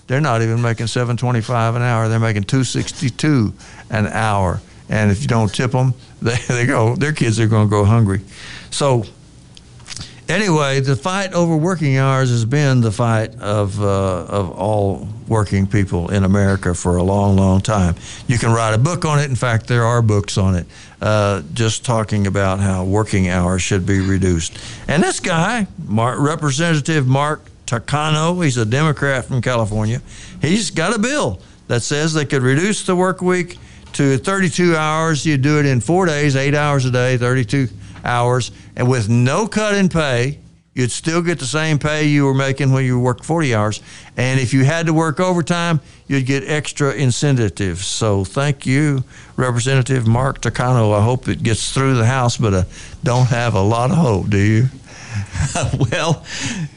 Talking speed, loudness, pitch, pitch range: 180 wpm, -17 LUFS, 125 Hz, 105-145 Hz